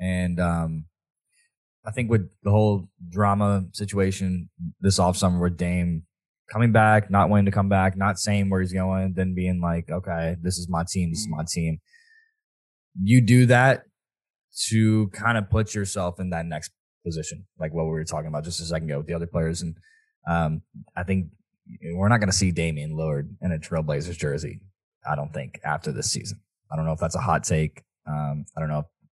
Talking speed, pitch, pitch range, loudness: 200 wpm, 90 Hz, 85-100 Hz, -24 LUFS